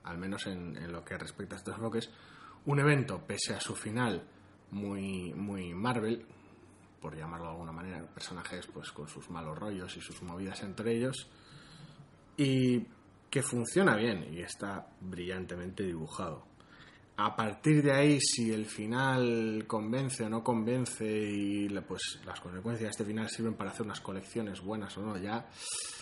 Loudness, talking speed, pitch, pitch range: -34 LUFS, 165 wpm, 110 Hz, 95-120 Hz